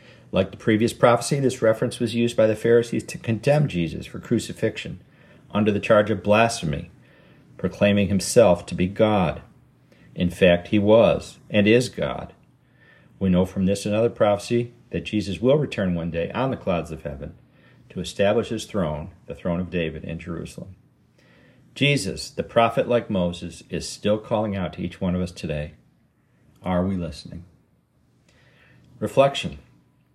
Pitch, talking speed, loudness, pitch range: 105 Hz, 160 wpm, -22 LUFS, 85-120 Hz